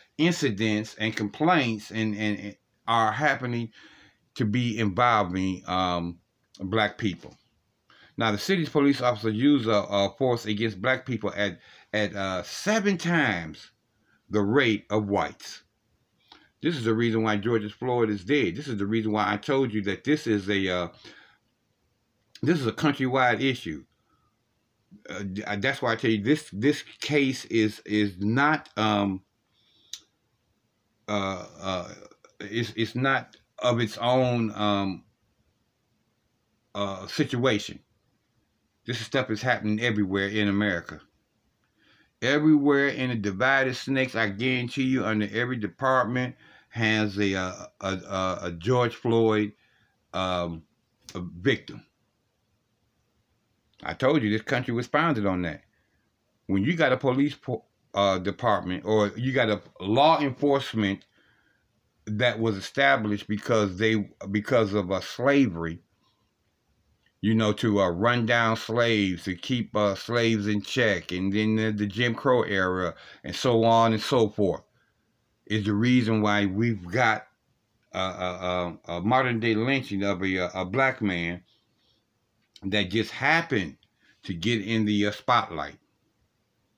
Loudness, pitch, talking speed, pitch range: -26 LUFS, 110 Hz, 140 wpm, 100-125 Hz